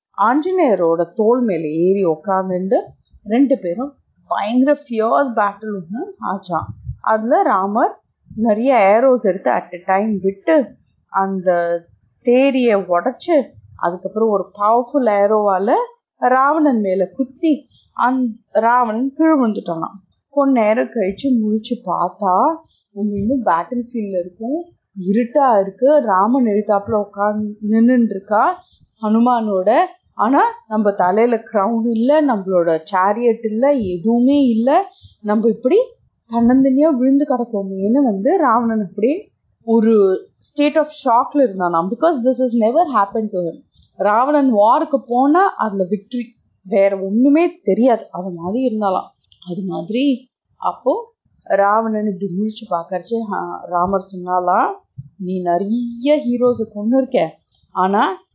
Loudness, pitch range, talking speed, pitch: -17 LUFS, 195-265 Hz, 110 wpm, 225 Hz